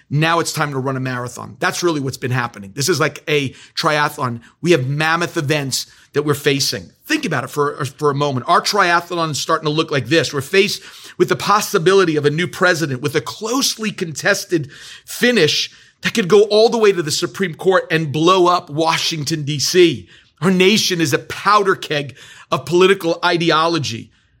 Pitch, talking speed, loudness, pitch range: 160 Hz, 190 wpm, -17 LUFS, 145-180 Hz